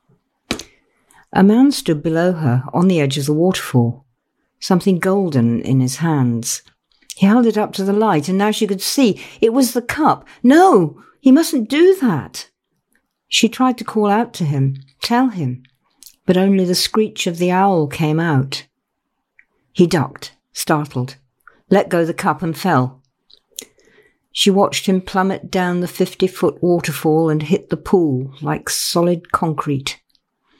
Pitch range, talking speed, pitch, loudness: 145-200 Hz, 155 wpm, 180 Hz, -16 LUFS